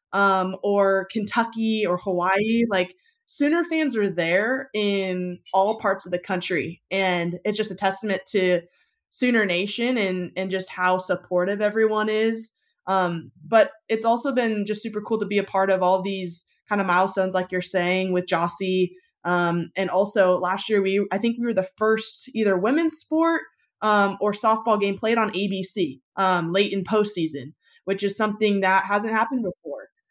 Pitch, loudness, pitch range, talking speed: 200 Hz, -23 LUFS, 185-220 Hz, 175 wpm